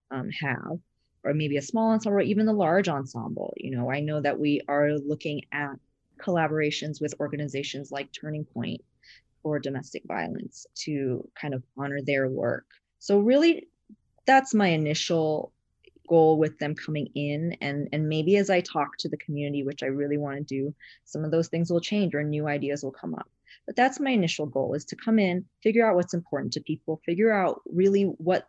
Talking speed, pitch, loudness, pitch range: 190 wpm, 155 Hz, -27 LUFS, 145-190 Hz